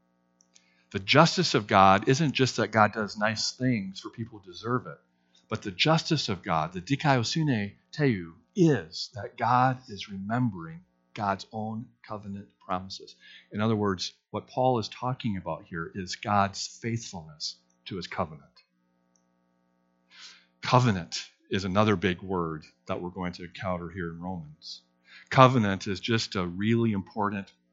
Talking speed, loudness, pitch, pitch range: 145 wpm, -27 LUFS, 100 Hz, 80-115 Hz